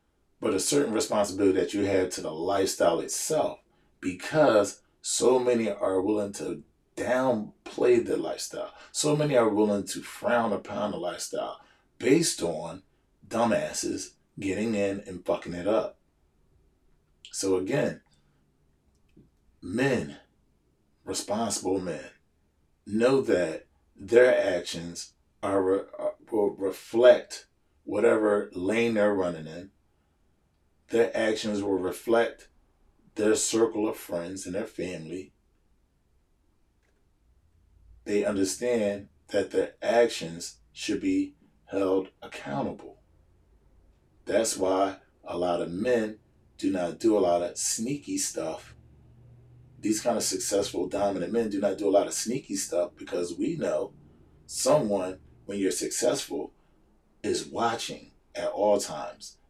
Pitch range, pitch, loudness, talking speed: 80-110 Hz, 95 Hz, -27 LUFS, 115 wpm